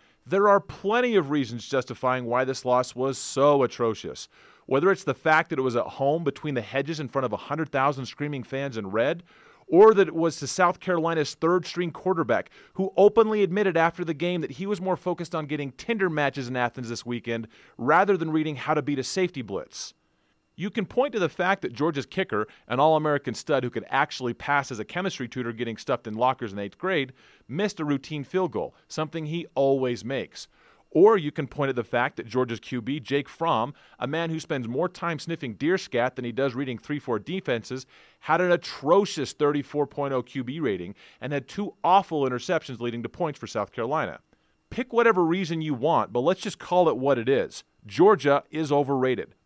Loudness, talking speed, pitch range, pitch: -25 LUFS, 205 wpm, 130-175 Hz, 145 Hz